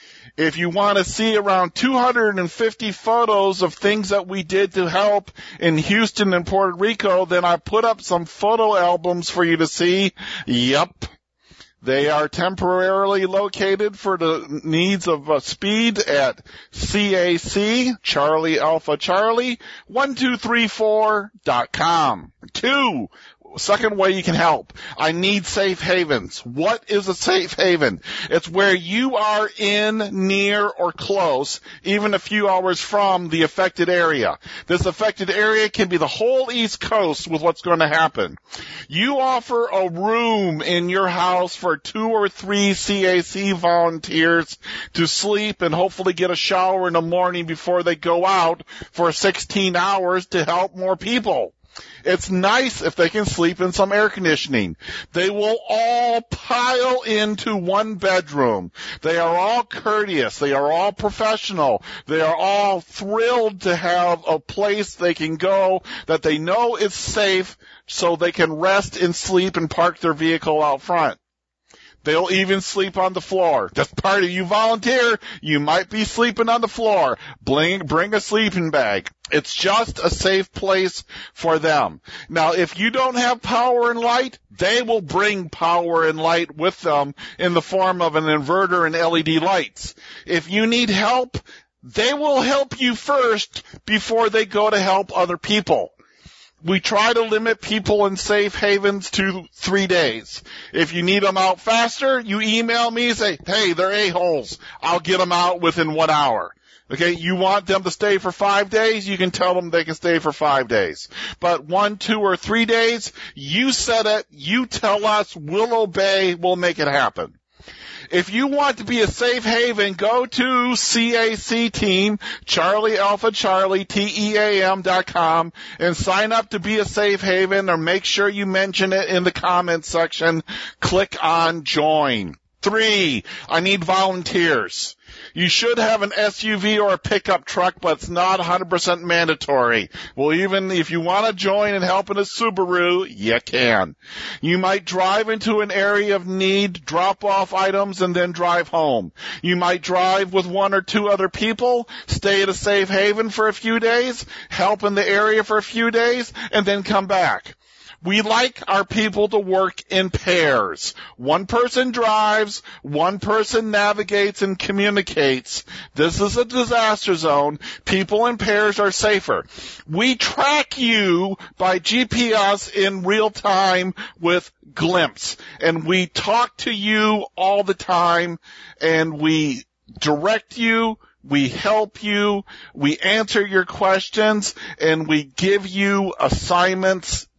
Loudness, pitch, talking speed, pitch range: -19 LUFS, 195 Hz, 160 wpm, 175-215 Hz